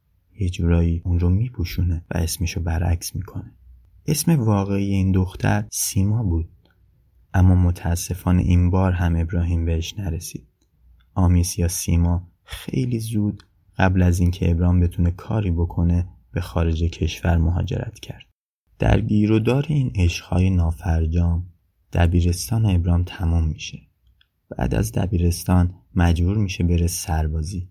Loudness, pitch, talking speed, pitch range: -21 LUFS, 90 Hz, 130 wpm, 85-95 Hz